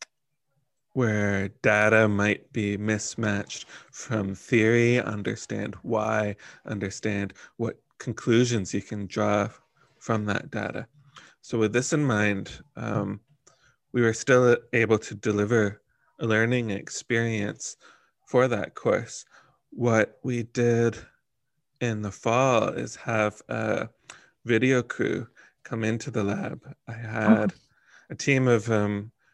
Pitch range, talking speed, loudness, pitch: 105-120 Hz, 115 wpm, -26 LUFS, 110 Hz